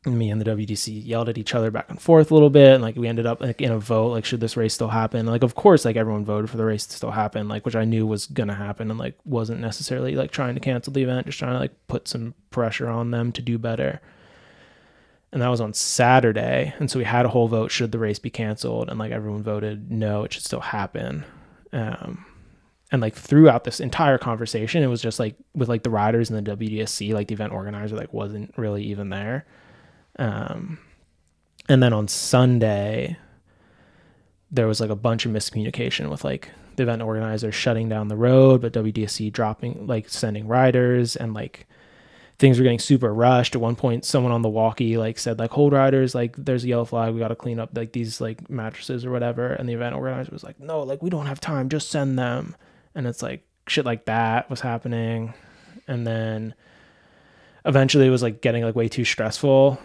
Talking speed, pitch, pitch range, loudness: 220 wpm, 115 Hz, 110-130 Hz, -22 LUFS